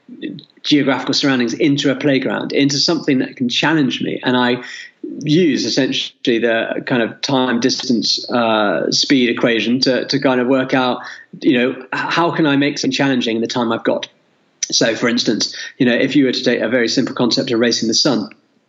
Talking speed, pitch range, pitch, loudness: 195 wpm, 125-140 Hz, 130 Hz, -16 LUFS